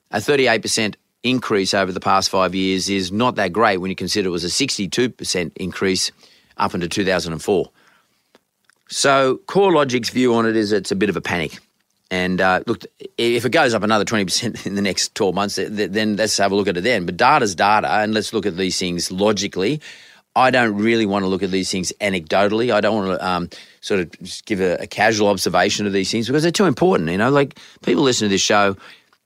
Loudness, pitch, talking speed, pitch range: -18 LUFS, 105 Hz, 215 wpm, 95-115 Hz